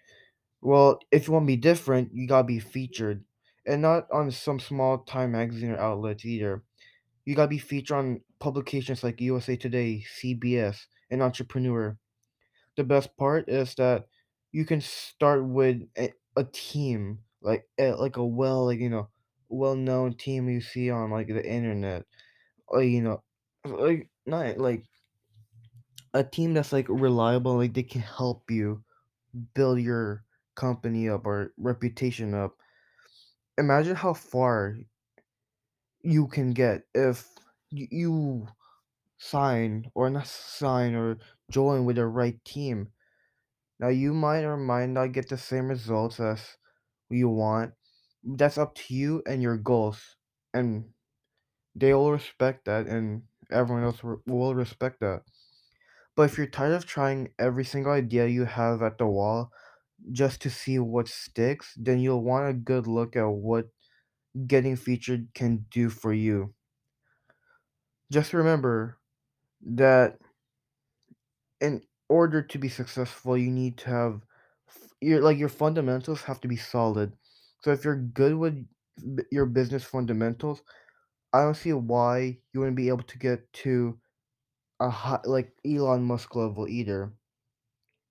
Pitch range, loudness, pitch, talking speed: 115-135 Hz, -27 LUFS, 125 Hz, 145 wpm